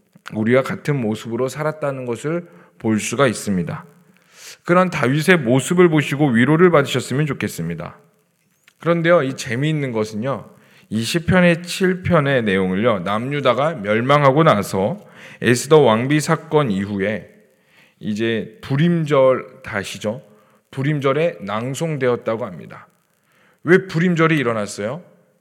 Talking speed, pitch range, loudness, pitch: 280 characters per minute, 115-160 Hz, -18 LUFS, 140 Hz